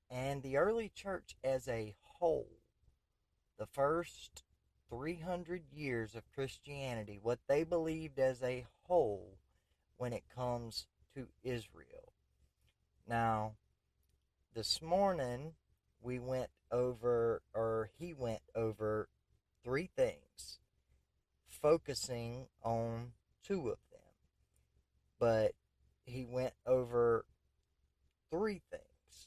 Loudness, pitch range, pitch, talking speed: -39 LUFS, 95-135 Hz, 120 Hz, 95 wpm